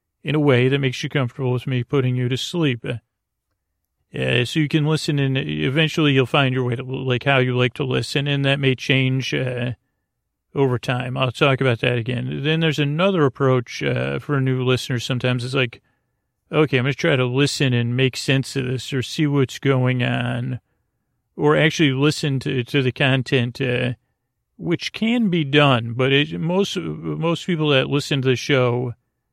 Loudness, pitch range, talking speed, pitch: -20 LUFS, 125-145 Hz, 190 wpm, 130 Hz